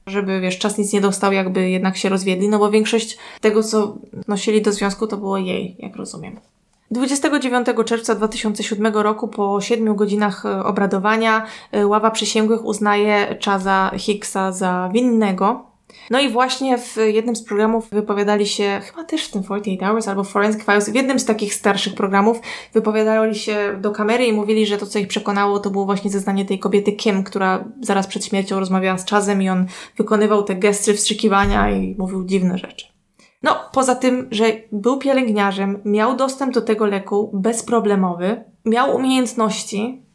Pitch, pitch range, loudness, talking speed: 210 Hz, 200-225 Hz, -18 LUFS, 165 wpm